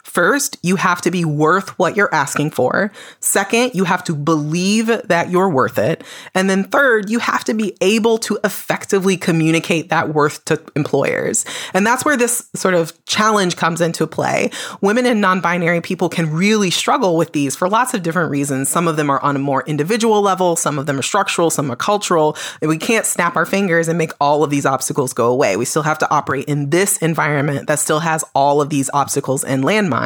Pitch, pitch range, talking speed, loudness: 170 Hz, 150-195 Hz, 210 wpm, -16 LUFS